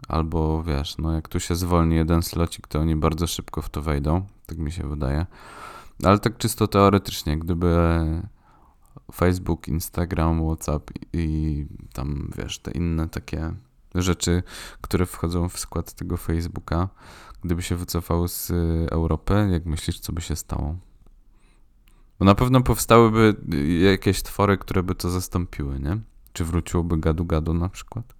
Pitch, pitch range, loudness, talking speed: 85 Hz, 80-95 Hz, -24 LUFS, 150 wpm